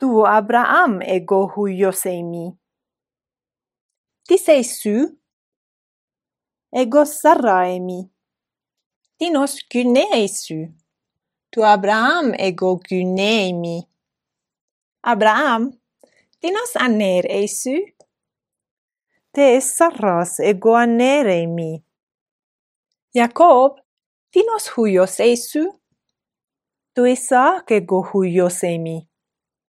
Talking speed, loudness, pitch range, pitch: 80 wpm, -17 LUFS, 185-275 Hz, 225 Hz